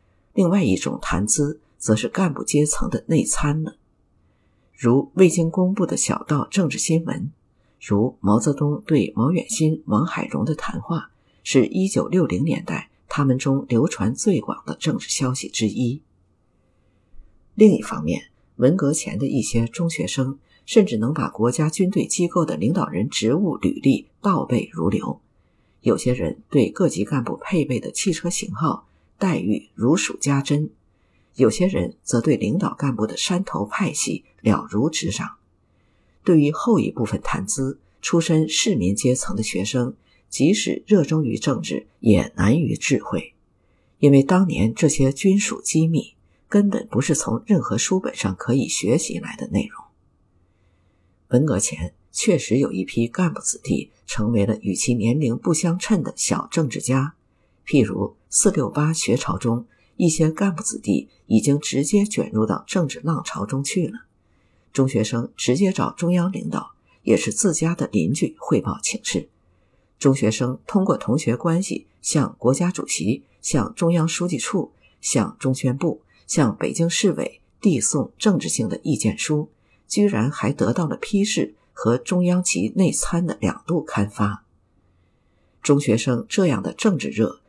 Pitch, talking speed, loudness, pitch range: 140 Hz, 230 characters per minute, -21 LUFS, 110-175 Hz